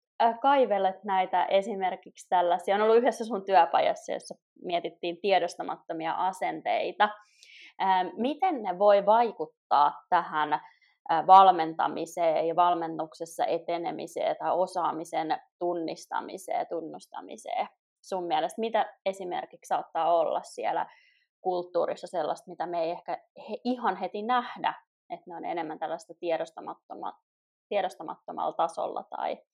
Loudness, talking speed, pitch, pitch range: -28 LUFS, 105 wpm, 190 Hz, 170-230 Hz